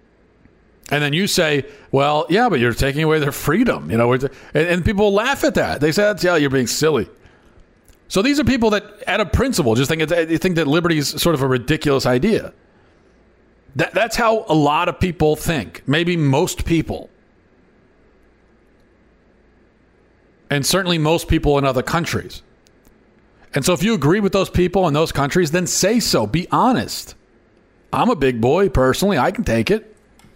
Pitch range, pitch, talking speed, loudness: 140-180 Hz, 155 Hz, 180 wpm, -18 LUFS